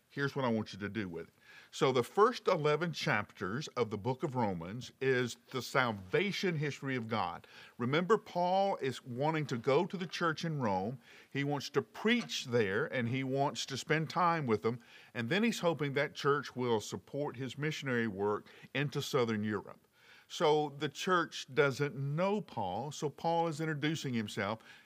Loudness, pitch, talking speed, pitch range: -34 LUFS, 140 Hz, 180 wpm, 120-160 Hz